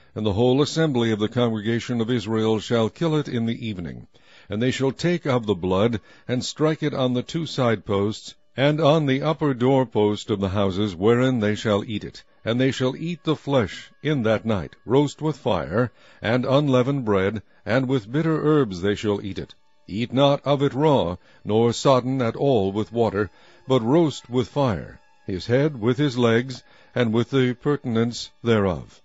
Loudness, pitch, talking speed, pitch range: -22 LUFS, 120 Hz, 190 wpm, 105-140 Hz